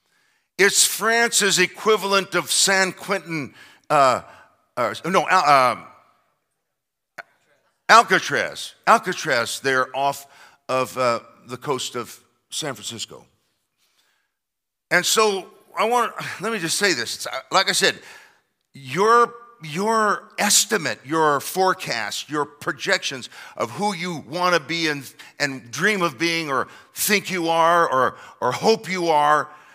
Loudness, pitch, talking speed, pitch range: -20 LUFS, 165 Hz, 125 wpm, 135-195 Hz